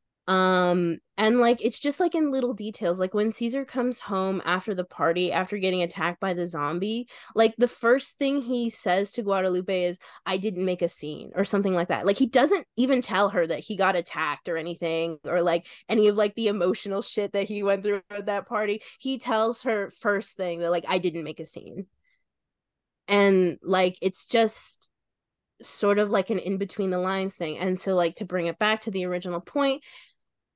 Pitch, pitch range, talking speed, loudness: 195 Hz, 180-220 Hz, 205 wpm, -26 LUFS